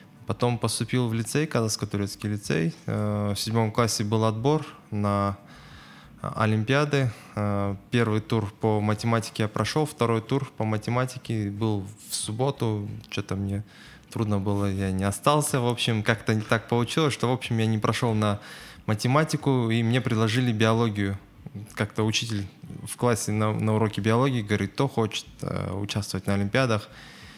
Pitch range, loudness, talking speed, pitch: 105-120 Hz, -26 LUFS, 140 wpm, 110 Hz